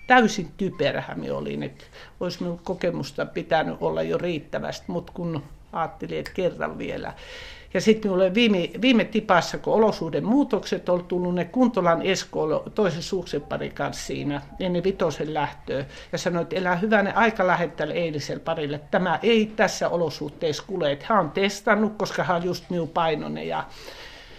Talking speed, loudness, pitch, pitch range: 155 wpm, -24 LUFS, 180 Hz, 165-205 Hz